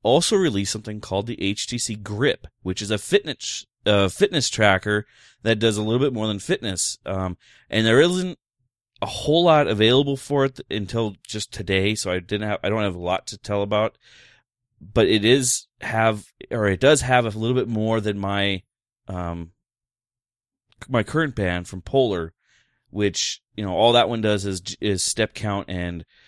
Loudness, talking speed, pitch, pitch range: -22 LUFS, 185 wpm, 105 Hz, 100-120 Hz